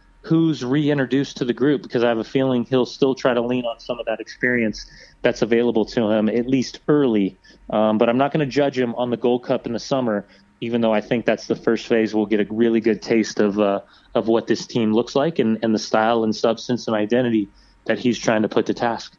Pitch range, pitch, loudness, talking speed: 110-125 Hz, 115 Hz, -20 LUFS, 245 wpm